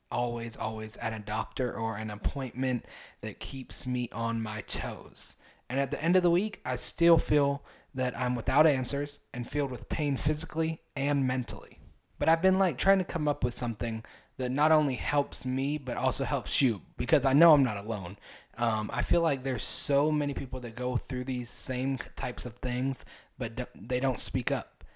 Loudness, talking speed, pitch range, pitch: -30 LUFS, 195 wpm, 120-145 Hz, 130 Hz